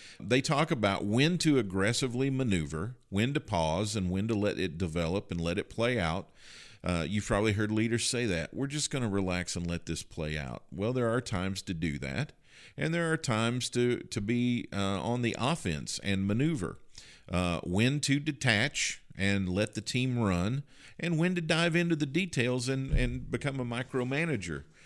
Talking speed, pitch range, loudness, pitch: 190 wpm, 95-130 Hz, -31 LUFS, 115 Hz